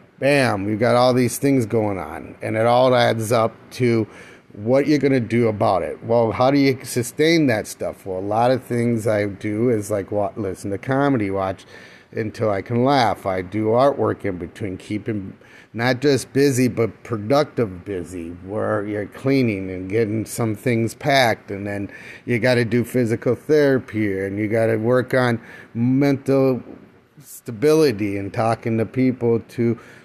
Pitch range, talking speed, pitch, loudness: 105-130 Hz, 170 wpm, 115 Hz, -20 LUFS